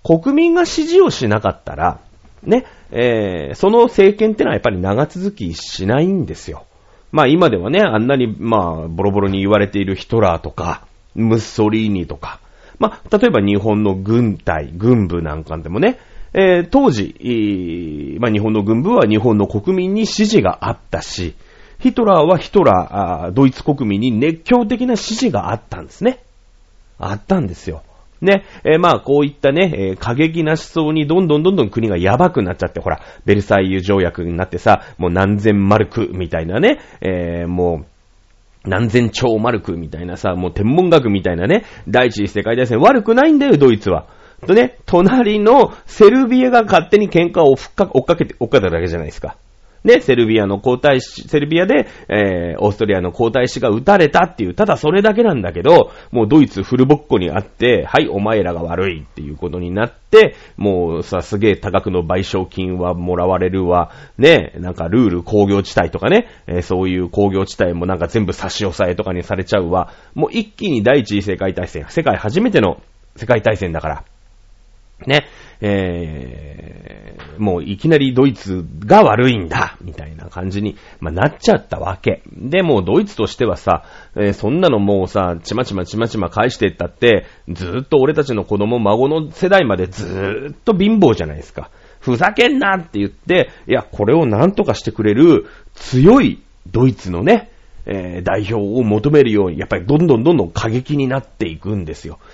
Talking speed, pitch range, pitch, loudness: 360 characters per minute, 90-150 Hz, 105 Hz, -15 LUFS